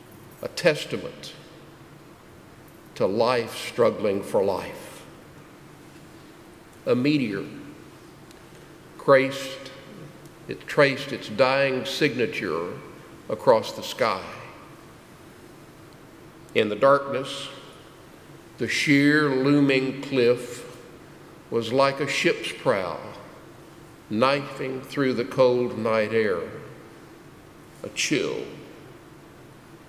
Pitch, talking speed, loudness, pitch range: 140 Hz, 75 wpm, -24 LUFS, 130-150 Hz